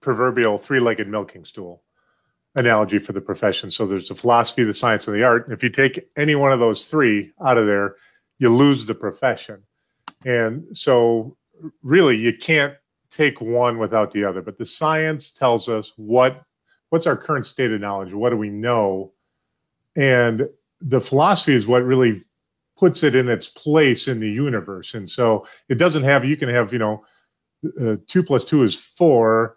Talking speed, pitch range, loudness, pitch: 180 wpm, 110-140 Hz, -19 LUFS, 120 Hz